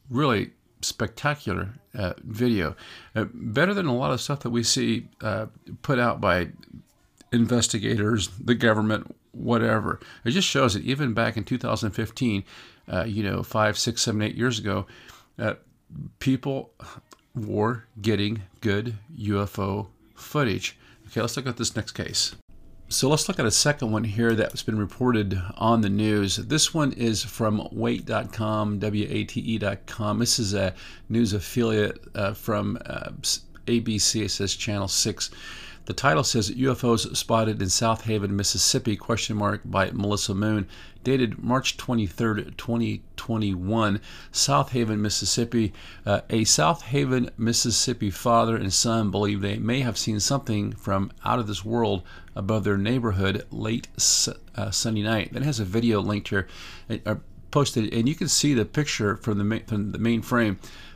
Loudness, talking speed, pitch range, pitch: -25 LUFS, 155 wpm, 100-120 Hz, 110 Hz